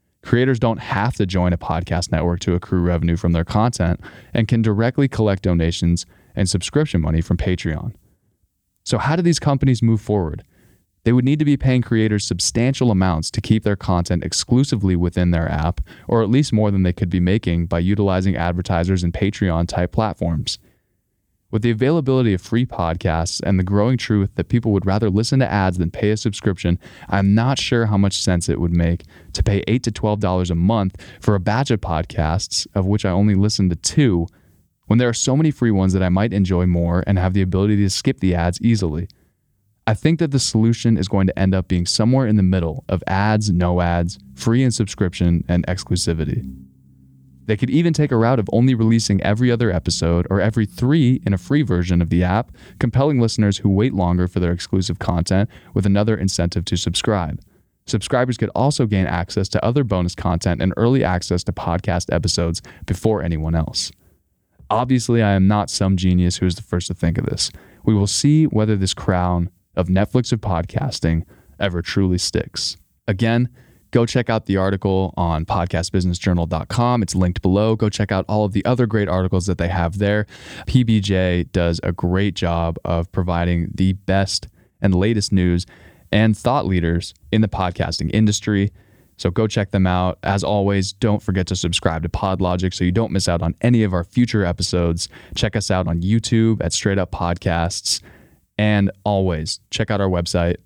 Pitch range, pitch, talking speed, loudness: 90-110 Hz, 95 Hz, 190 wpm, -19 LUFS